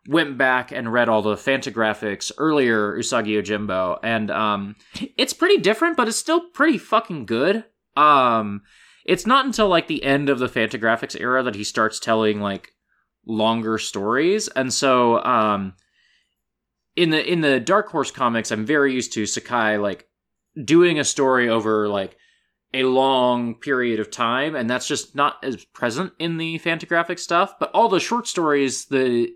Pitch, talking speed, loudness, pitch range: 130 Hz, 165 wpm, -20 LUFS, 110-165 Hz